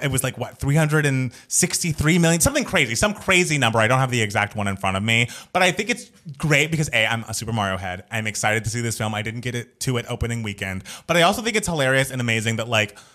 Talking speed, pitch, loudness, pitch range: 260 wpm, 125 Hz, -21 LUFS, 110-160 Hz